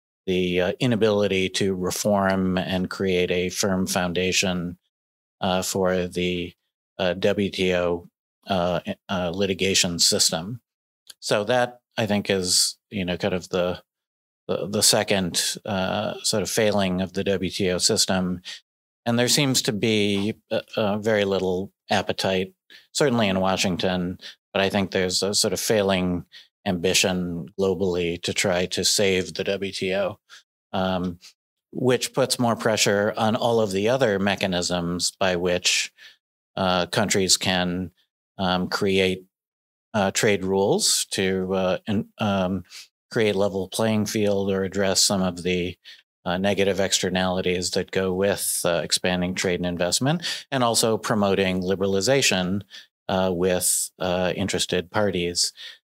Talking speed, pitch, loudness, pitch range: 130 wpm, 95 Hz, -23 LUFS, 90-100 Hz